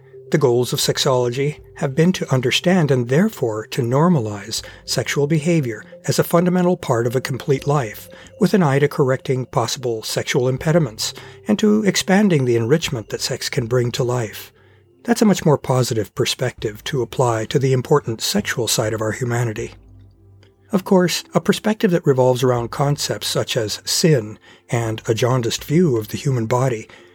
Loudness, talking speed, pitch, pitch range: -19 LUFS, 170 wpm, 130 Hz, 115-155 Hz